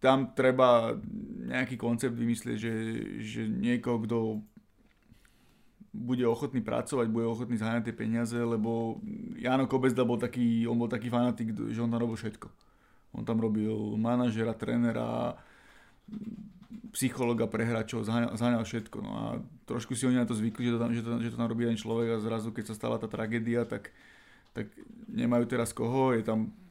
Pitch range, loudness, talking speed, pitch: 115-125 Hz, -31 LUFS, 165 wpm, 115 Hz